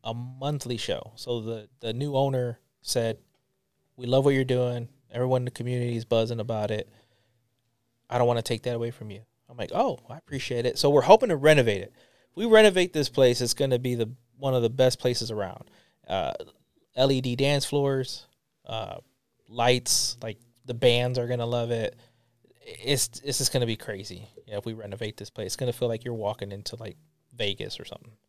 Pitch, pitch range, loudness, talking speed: 120 Hz, 115-130 Hz, -26 LUFS, 205 wpm